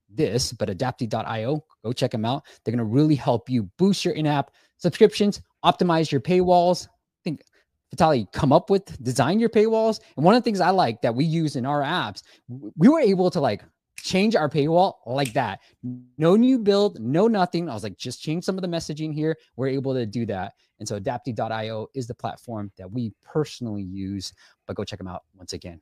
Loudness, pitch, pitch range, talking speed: -23 LUFS, 140 Hz, 115-175 Hz, 210 wpm